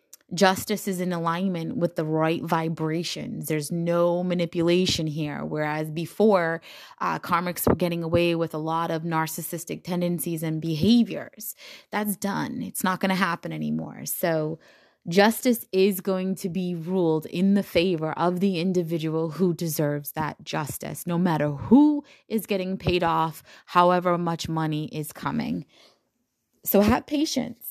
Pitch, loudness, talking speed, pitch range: 175 Hz, -25 LUFS, 145 wpm, 160-195 Hz